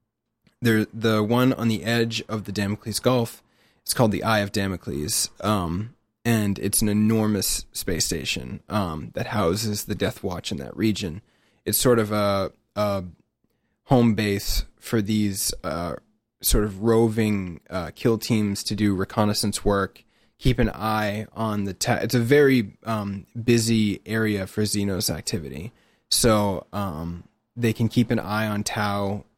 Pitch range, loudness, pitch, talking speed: 100-115 Hz, -24 LUFS, 105 Hz, 155 wpm